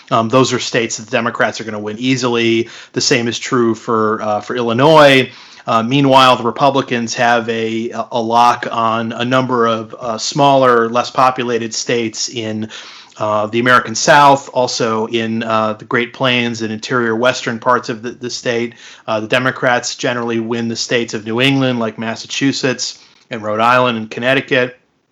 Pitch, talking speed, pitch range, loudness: 120 Hz, 175 wpm, 115-125 Hz, -14 LUFS